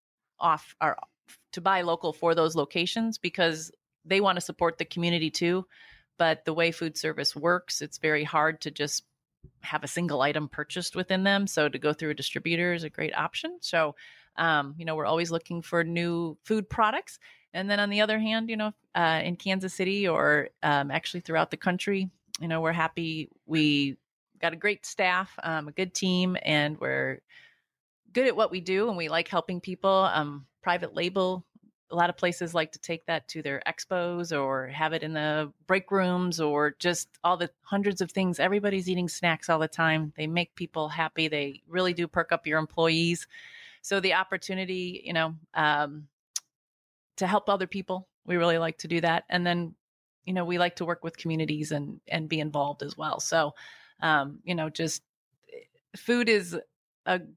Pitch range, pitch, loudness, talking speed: 155-185 Hz, 170 Hz, -28 LUFS, 190 wpm